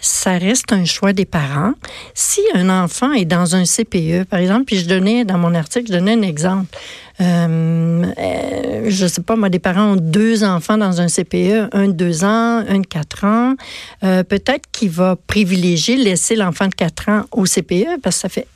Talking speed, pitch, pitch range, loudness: 205 wpm, 195 Hz, 180-215 Hz, -15 LUFS